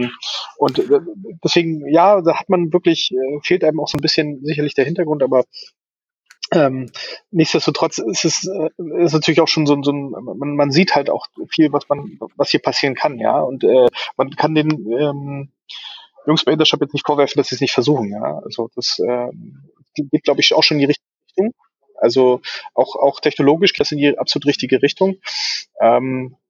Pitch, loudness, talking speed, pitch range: 155 Hz, -17 LUFS, 185 wpm, 145-175 Hz